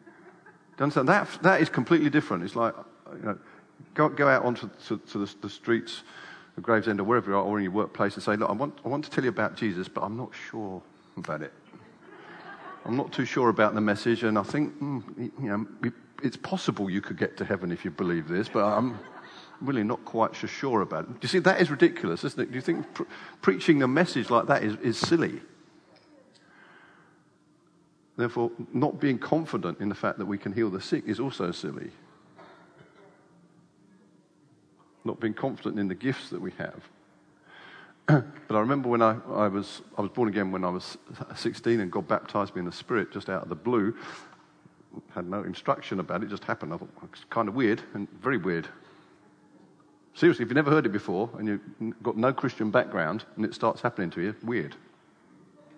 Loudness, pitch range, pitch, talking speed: -28 LUFS, 105-150 Hz, 120 Hz, 205 wpm